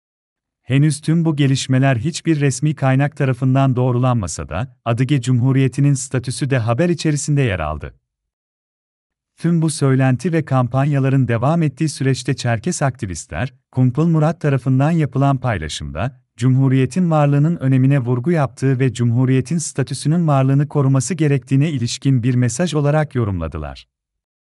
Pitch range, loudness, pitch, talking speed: 125-145 Hz, -17 LUFS, 135 Hz, 120 wpm